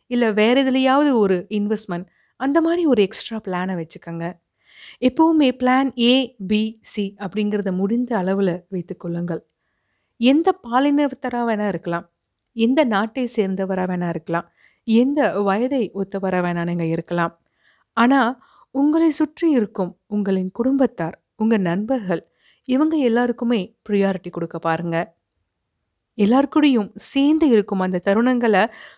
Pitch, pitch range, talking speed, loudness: 210 Hz, 180-255 Hz, 110 wpm, -20 LUFS